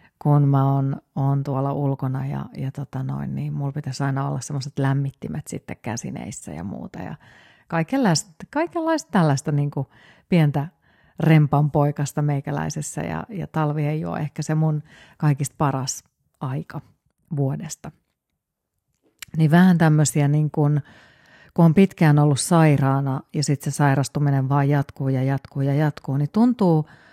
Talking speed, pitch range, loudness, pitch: 145 wpm, 140-155 Hz, -22 LUFS, 145 Hz